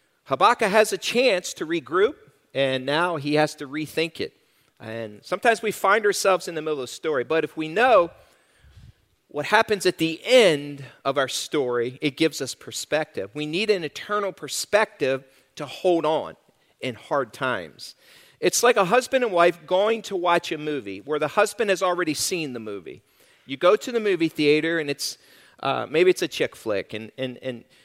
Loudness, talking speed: -23 LUFS, 185 wpm